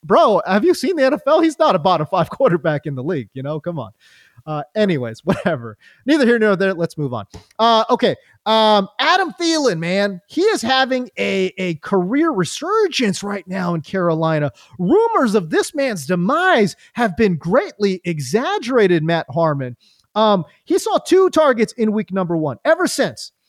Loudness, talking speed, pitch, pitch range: -17 LUFS, 175 wpm, 200 Hz, 170-265 Hz